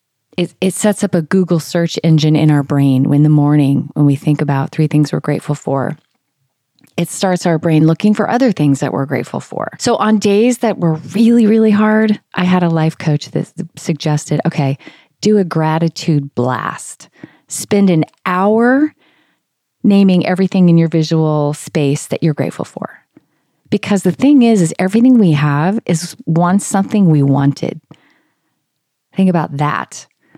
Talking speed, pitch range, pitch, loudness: 170 wpm, 150-200 Hz, 165 Hz, -13 LUFS